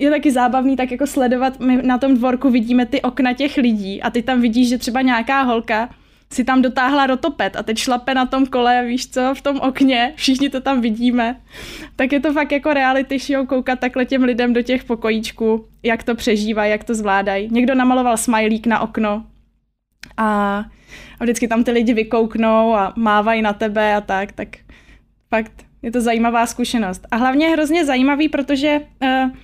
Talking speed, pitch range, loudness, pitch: 190 wpm, 225-265 Hz, -17 LUFS, 250 Hz